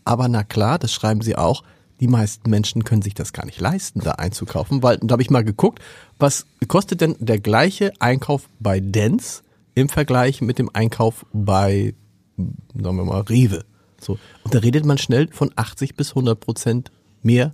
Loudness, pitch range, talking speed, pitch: -20 LUFS, 105-130 Hz, 185 wpm, 115 Hz